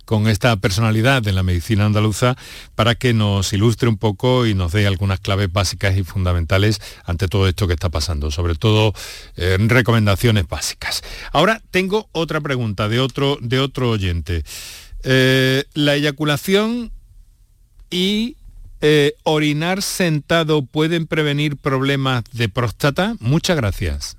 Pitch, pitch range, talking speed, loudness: 115 Hz, 100-145 Hz, 135 wpm, -18 LUFS